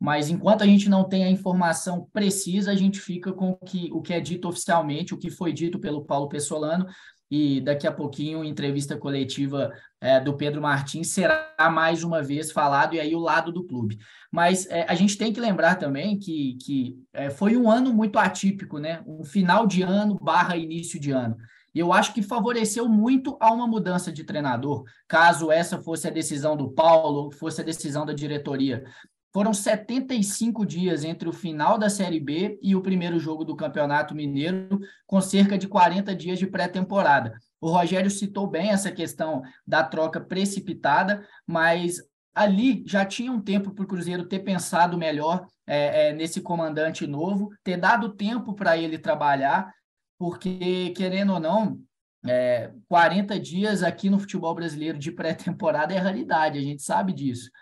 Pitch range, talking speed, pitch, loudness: 155-195 Hz, 175 wpm, 175 Hz, -24 LUFS